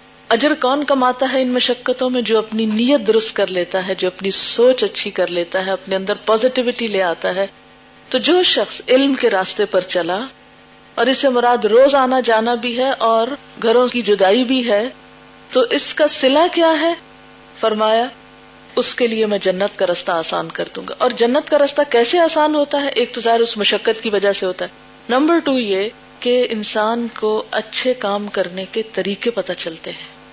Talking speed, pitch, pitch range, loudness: 195 wpm, 235 Hz, 205-260 Hz, -16 LUFS